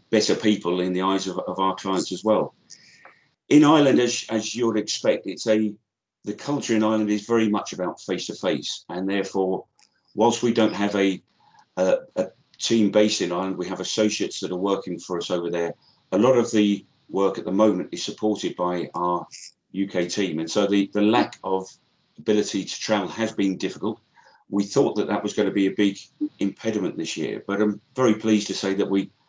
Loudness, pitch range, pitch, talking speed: -23 LUFS, 95-110 Hz, 100 Hz, 205 wpm